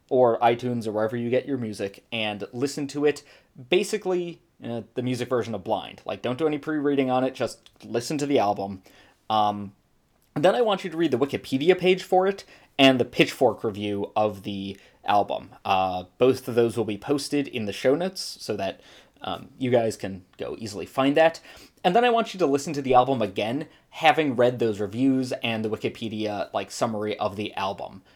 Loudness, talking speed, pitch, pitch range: -25 LUFS, 200 wpm, 125 Hz, 105-145 Hz